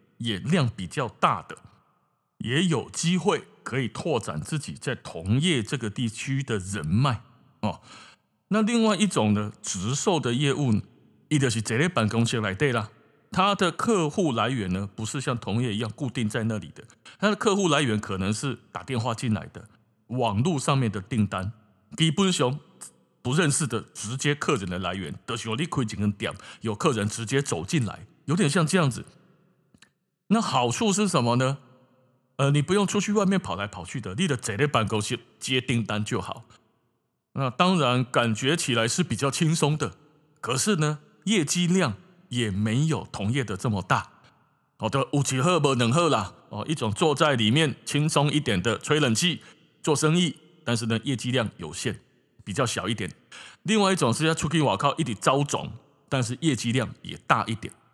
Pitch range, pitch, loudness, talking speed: 110-160 Hz, 130 Hz, -25 LUFS, 260 characters per minute